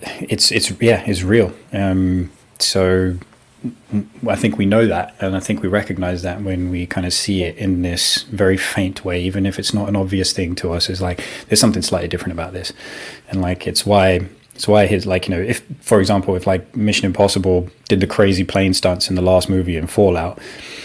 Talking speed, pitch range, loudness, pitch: 215 wpm, 90-100 Hz, -17 LUFS, 95 Hz